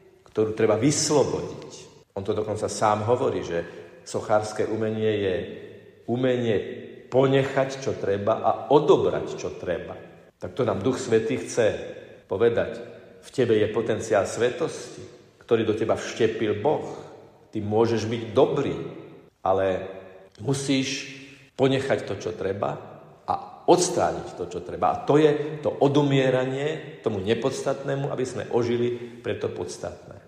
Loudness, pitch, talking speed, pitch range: -25 LUFS, 130 Hz, 130 wpm, 110-145 Hz